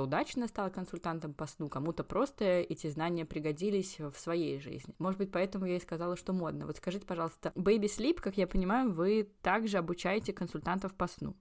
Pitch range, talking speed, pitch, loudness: 165-200 Hz, 185 wpm, 180 Hz, -35 LUFS